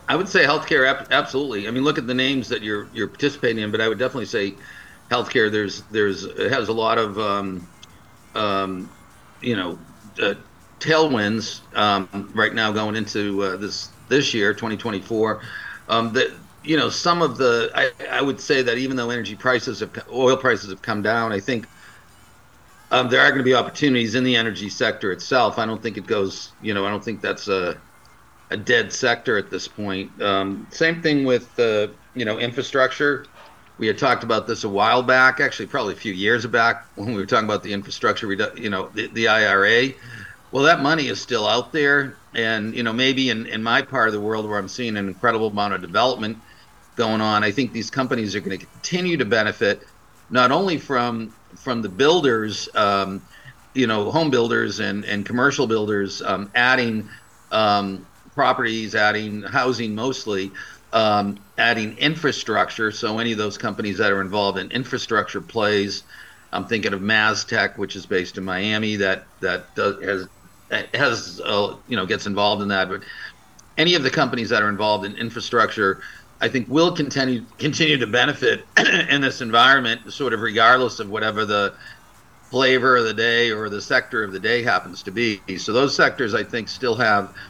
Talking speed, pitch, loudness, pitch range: 190 wpm, 110 Hz, -20 LUFS, 105-125 Hz